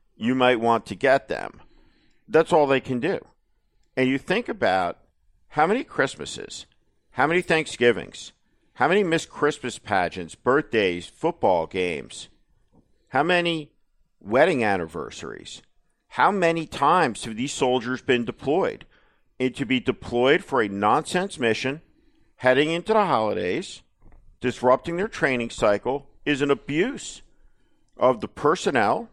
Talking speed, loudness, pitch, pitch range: 130 wpm, -23 LUFS, 130 Hz, 120-165 Hz